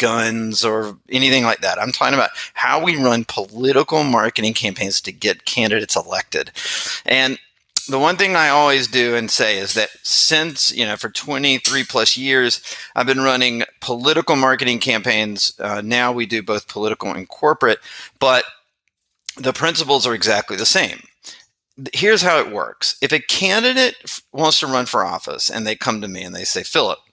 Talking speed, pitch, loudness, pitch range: 175 wpm, 125 Hz, -17 LUFS, 110-140 Hz